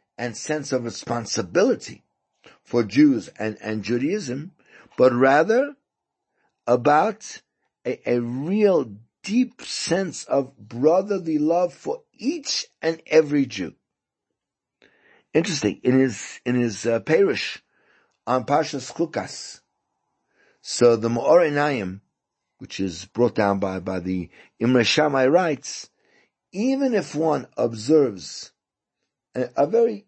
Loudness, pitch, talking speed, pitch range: -22 LUFS, 140 Hz, 110 wpm, 120-180 Hz